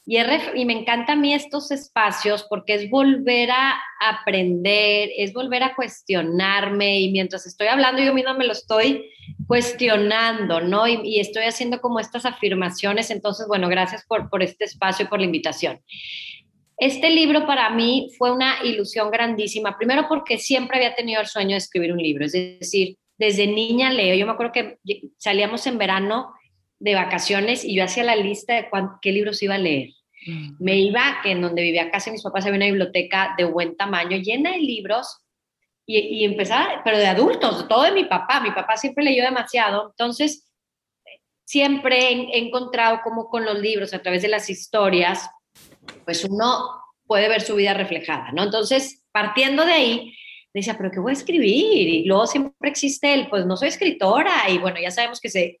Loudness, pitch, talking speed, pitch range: -20 LUFS, 215 Hz, 185 wpm, 195-250 Hz